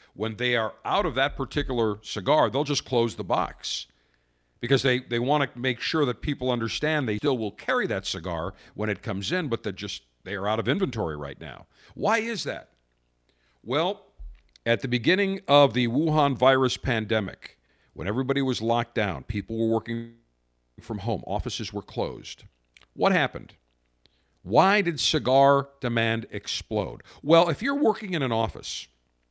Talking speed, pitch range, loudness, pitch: 165 wpm, 95-140 Hz, -26 LUFS, 115 Hz